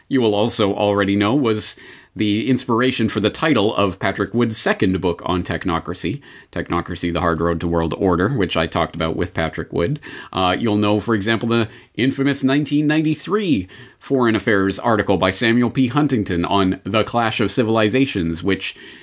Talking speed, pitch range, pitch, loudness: 165 wpm, 90-120 Hz, 105 Hz, -19 LUFS